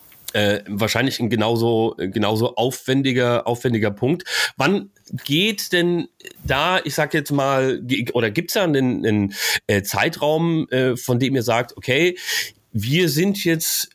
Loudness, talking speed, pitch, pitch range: -20 LUFS, 130 wpm, 130 Hz, 115-165 Hz